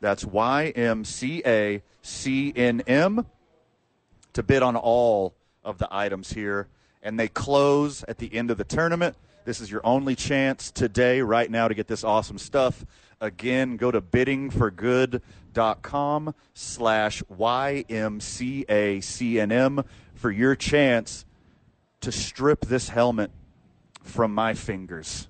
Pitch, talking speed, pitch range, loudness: 115 Hz, 115 wpm, 105-130 Hz, -25 LUFS